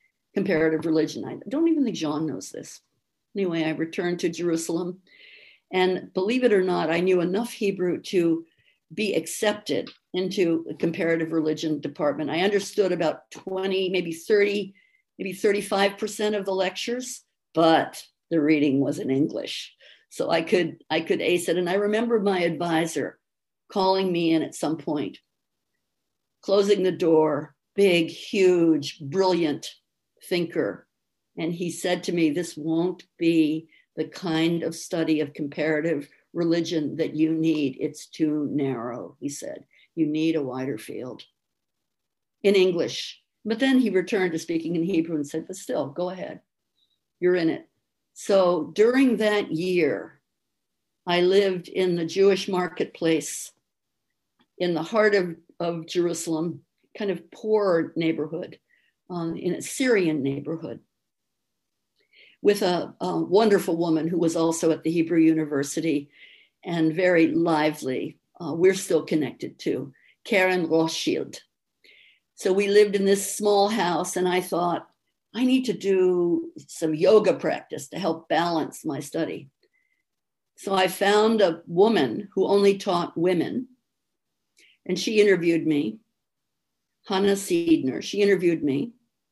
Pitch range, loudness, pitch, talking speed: 160-200 Hz, -24 LUFS, 175 Hz, 140 wpm